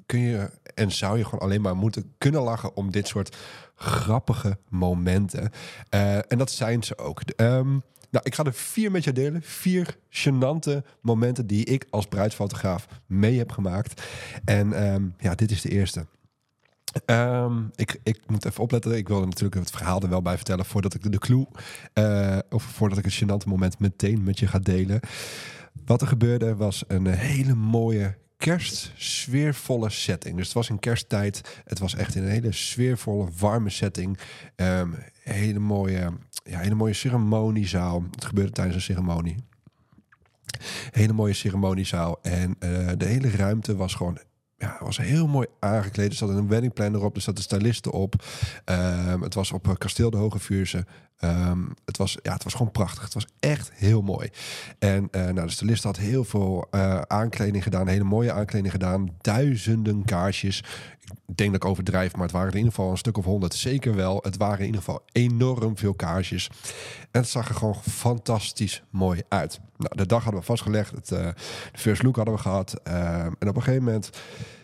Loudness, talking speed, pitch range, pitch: -26 LUFS, 185 wpm, 95-120 Hz, 105 Hz